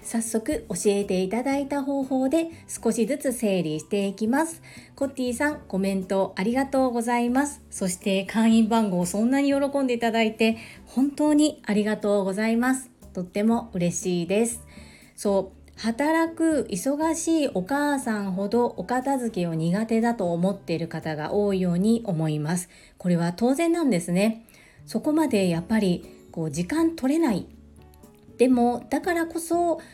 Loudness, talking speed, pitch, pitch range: -25 LUFS, 315 characters per minute, 225 Hz, 190-275 Hz